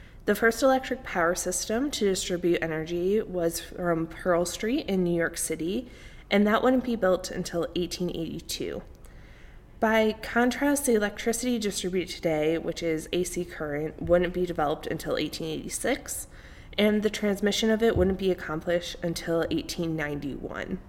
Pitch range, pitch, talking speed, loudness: 170-215 Hz, 180 Hz, 140 wpm, -27 LUFS